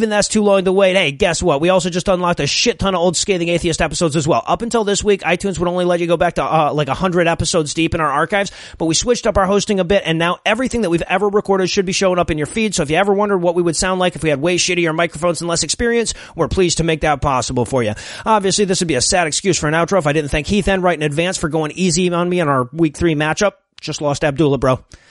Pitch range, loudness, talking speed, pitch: 160-195 Hz, -16 LUFS, 300 wpm, 175 Hz